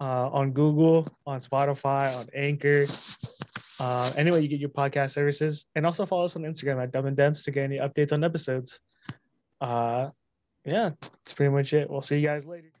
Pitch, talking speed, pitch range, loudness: 145 Hz, 190 wpm, 135-150 Hz, -27 LUFS